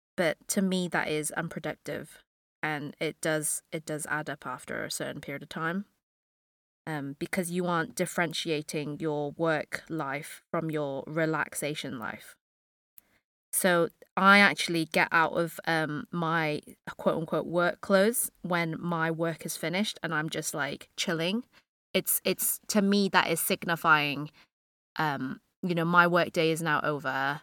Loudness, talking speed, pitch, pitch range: -29 LUFS, 150 wpm, 160 Hz, 150-175 Hz